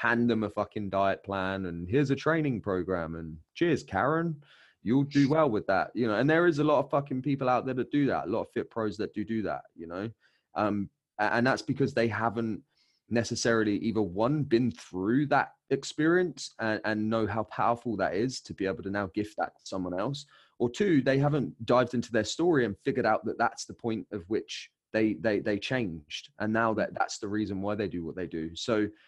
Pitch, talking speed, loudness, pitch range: 115 Hz, 225 wpm, -29 LUFS, 100-130 Hz